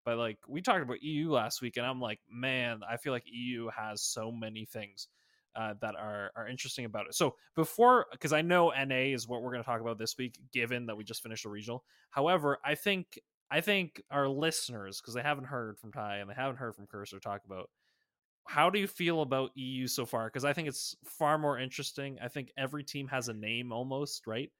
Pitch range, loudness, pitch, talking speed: 115-145 Hz, -34 LUFS, 125 Hz, 230 wpm